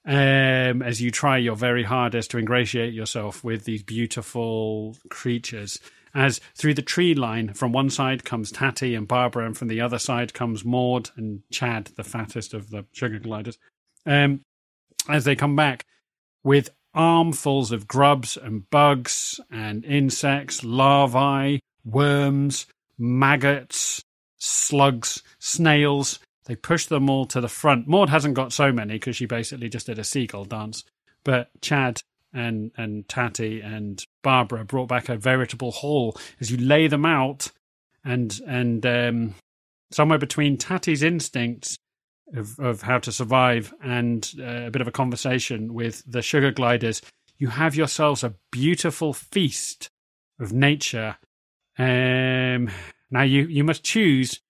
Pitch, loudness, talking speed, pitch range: 125 Hz, -23 LUFS, 145 wpm, 115-140 Hz